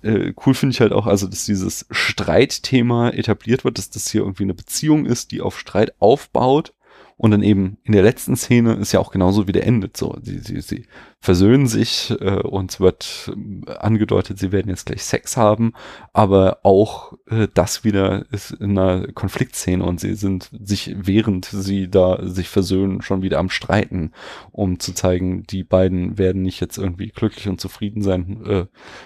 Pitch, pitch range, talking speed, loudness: 100 Hz, 95-110 Hz, 180 wpm, -19 LUFS